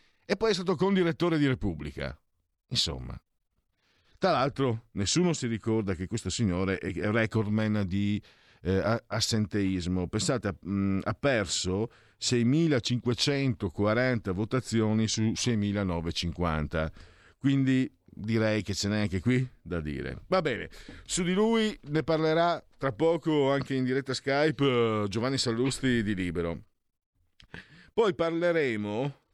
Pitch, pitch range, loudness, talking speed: 110 Hz, 95-135 Hz, -29 LUFS, 115 wpm